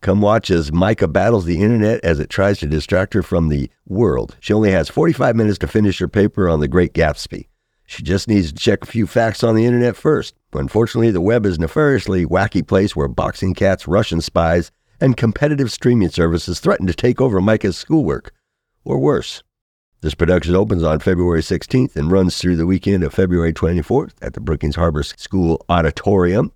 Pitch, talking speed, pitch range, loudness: 95 Hz, 195 wpm, 85-110 Hz, -17 LUFS